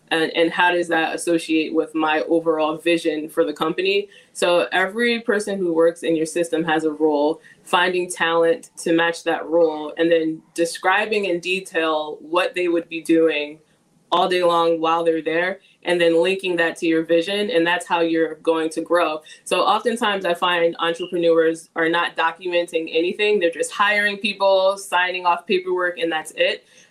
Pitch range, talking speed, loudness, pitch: 165-180 Hz, 175 wpm, -20 LUFS, 170 Hz